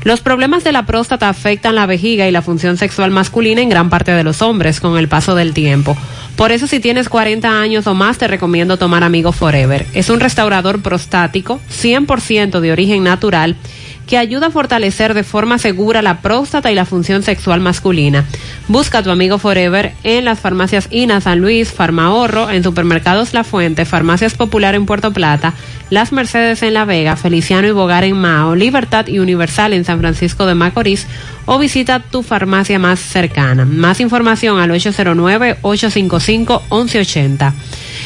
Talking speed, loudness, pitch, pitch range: 170 wpm, -12 LUFS, 195 Hz, 170-225 Hz